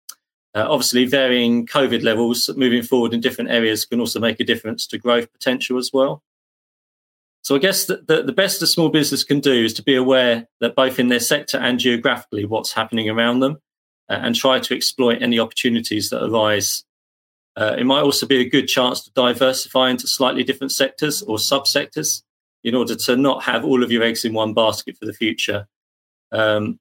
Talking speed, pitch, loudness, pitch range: 195 wpm, 120 Hz, -18 LUFS, 110-135 Hz